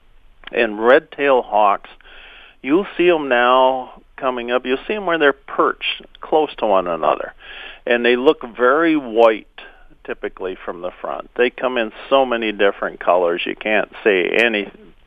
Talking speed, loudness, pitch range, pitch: 160 wpm, -17 LUFS, 120-135 Hz, 125 Hz